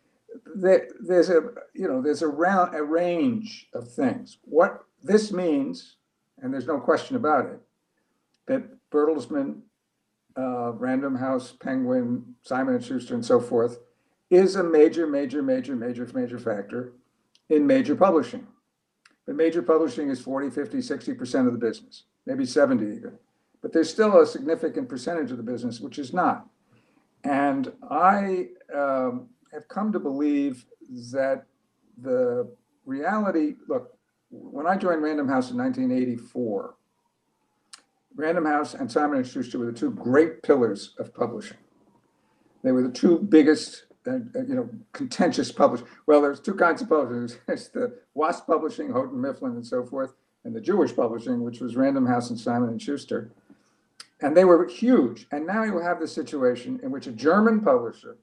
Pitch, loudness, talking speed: 185 Hz, -24 LUFS, 155 wpm